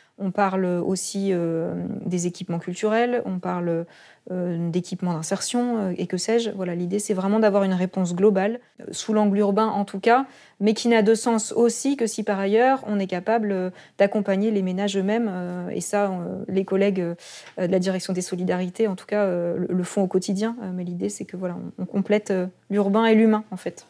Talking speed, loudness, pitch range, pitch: 215 wpm, -23 LUFS, 185-215 Hz, 195 Hz